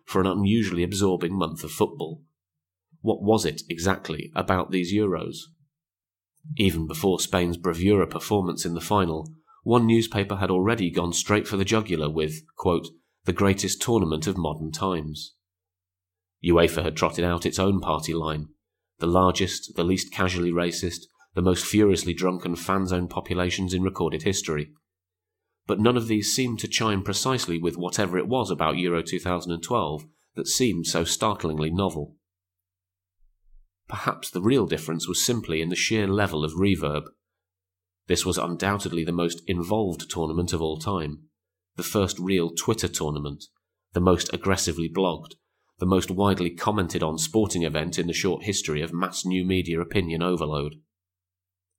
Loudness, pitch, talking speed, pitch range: -25 LUFS, 90 Hz, 150 wpm, 85-95 Hz